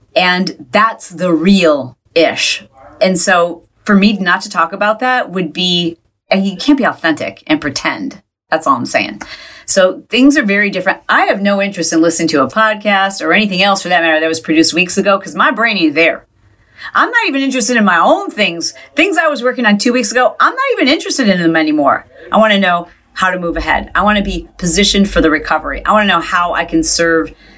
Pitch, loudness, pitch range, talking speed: 190 Hz, -12 LUFS, 165-215 Hz, 225 wpm